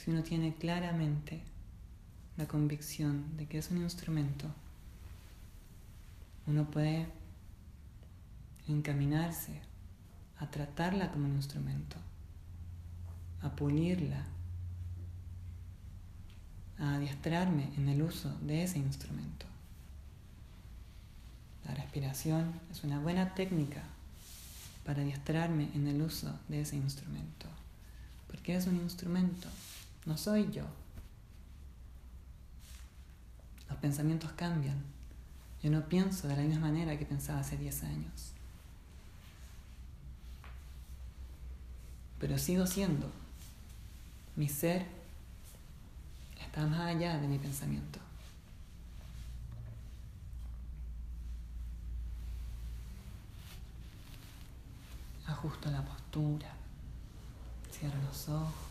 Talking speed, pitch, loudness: 85 wpm, 95 Hz, -38 LUFS